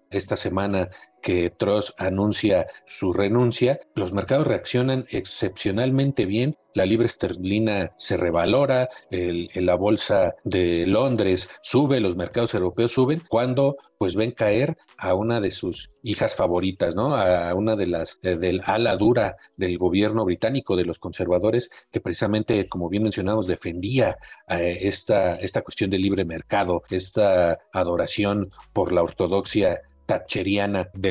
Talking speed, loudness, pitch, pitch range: 140 wpm, -23 LUFS, 100 Hz, 90-115 Hz